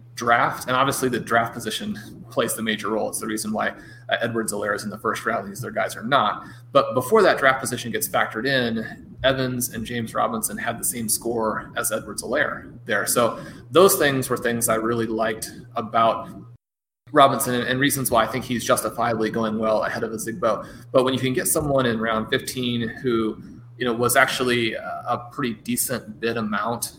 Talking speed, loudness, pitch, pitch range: 200 wpm, -22 LUFS, 120 Hz, 110-130 Hz